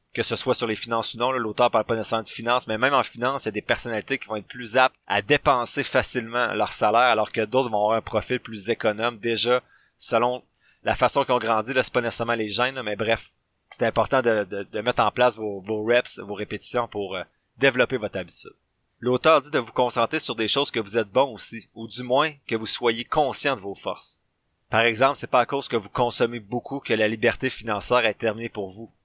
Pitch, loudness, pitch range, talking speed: 115 Hz, -24 LUFS, 110-125 Hz, 240 wpm